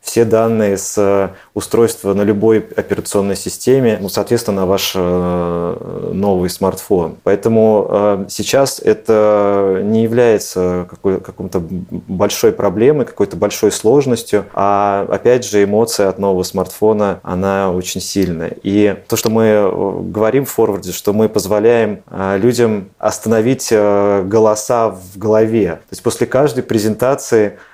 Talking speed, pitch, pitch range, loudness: 120 wpm, 105 Hz, 95-115 Hz, -14 LUFS